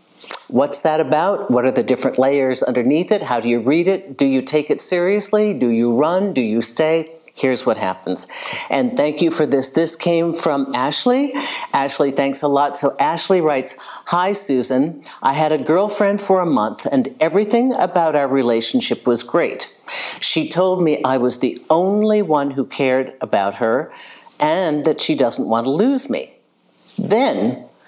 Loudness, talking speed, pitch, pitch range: -17 LUFS, 175 wpm, 155 Hz, 135-190 Hz